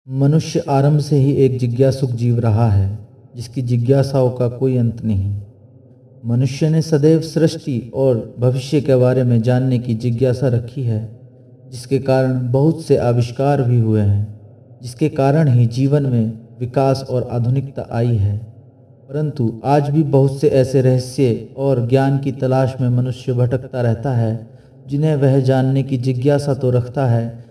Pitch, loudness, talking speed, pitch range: 130 Hz, -17 LUFS, 155 wpm, 120-135 Hz